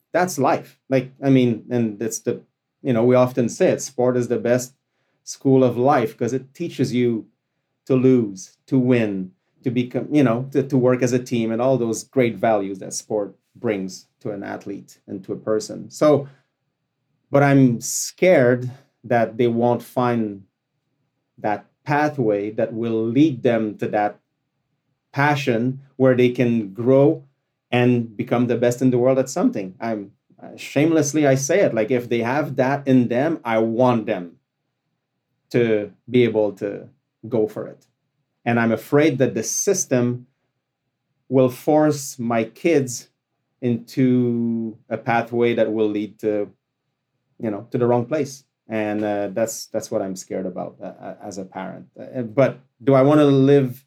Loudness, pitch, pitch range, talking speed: -20 LUFS, 125 Hz, 115-135 Hz, 165 wpm